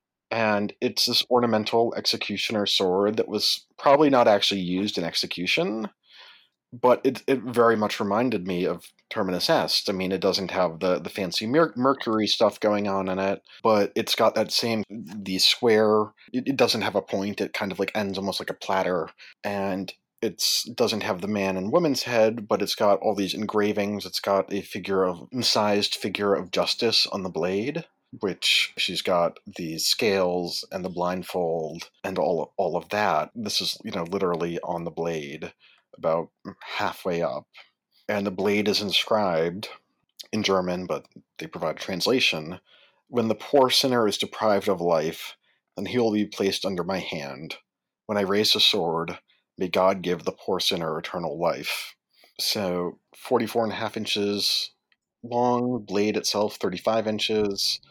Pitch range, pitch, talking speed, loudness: 95-110 Hz, 100 Hz, 170 wpm, -24 LUFS